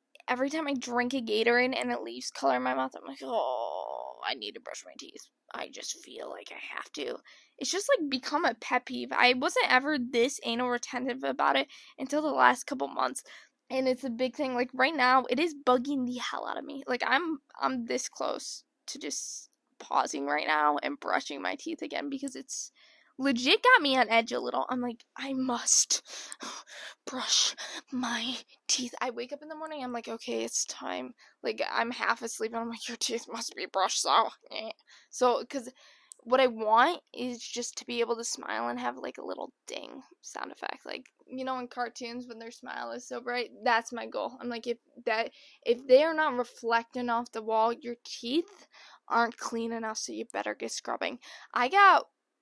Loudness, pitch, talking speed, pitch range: -30 LUFS, 245 Hz, 205 wpm, 230-270 Hz